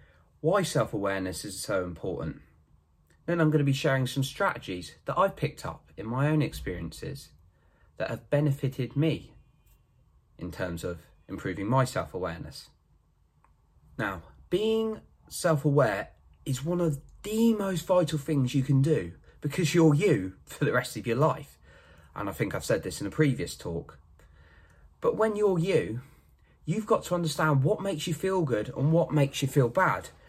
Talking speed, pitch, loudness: 170 wpm, 140 Hz, -28 LUFS